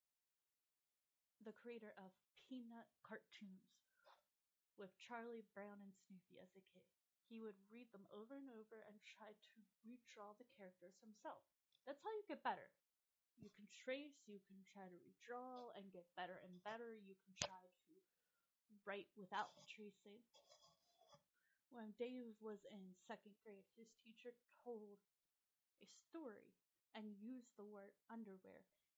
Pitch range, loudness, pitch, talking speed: 195-240 Hz, -57 LUFS, 215 Hz, 140 wpm